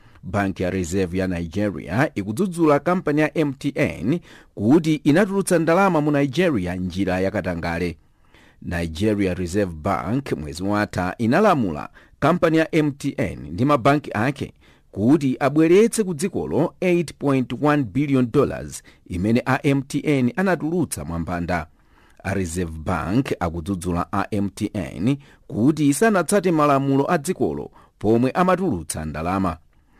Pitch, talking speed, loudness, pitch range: 115 Hz, 100 wpm, -21 LUFS, 90-150 Hz